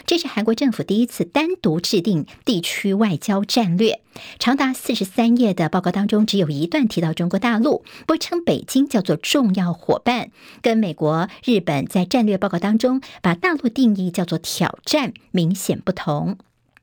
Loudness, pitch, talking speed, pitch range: -20 LUFS, 210 Hz, 270 characters per minute, 180-245 Hz